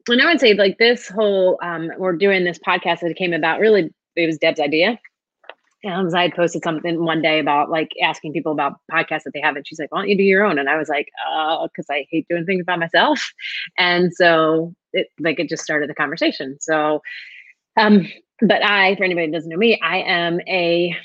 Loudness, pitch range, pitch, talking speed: -18 LUFS, 160-195 Hz, 170 Hz, 230 wpm